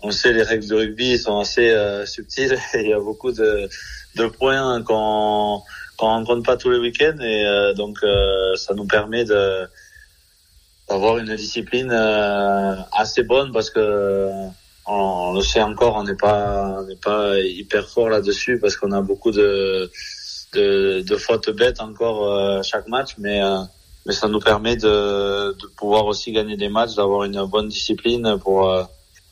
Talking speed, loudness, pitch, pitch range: 175 wpm, -19 LUFS, 105 Hz, 100-120 Hz